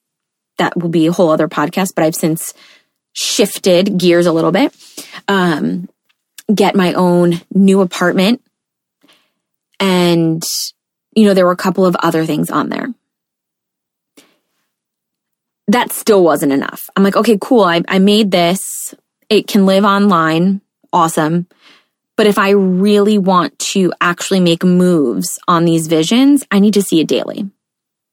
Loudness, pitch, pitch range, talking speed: -13 LUFS, 185 Hz, 170-205 Hz, 145 wpm